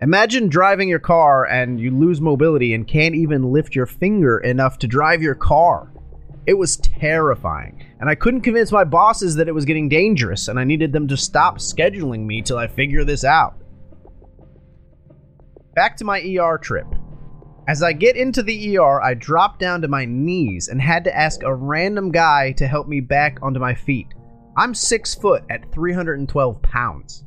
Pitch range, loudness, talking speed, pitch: 125-175 Hz, -17 LUFS, 185 wpm, 150 Hz